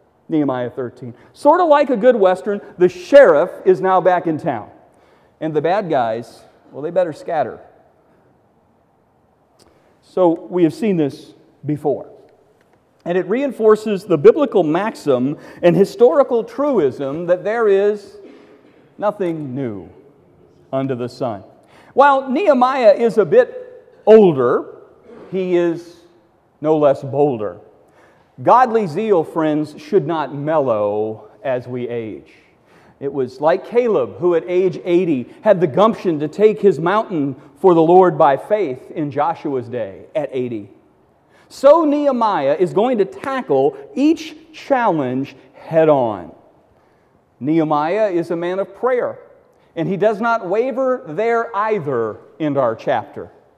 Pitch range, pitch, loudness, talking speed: 155-245 Hz, 185 Hz, -17 LUFS, 130 wpm